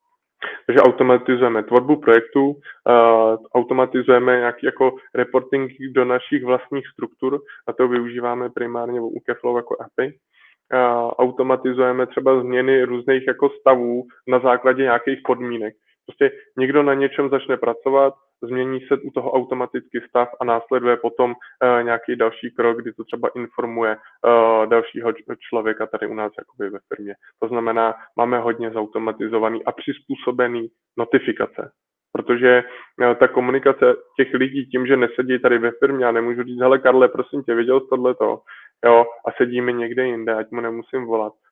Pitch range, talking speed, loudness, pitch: 120-130 Hz, 150 wpm, -19 LUFS, 125 Hz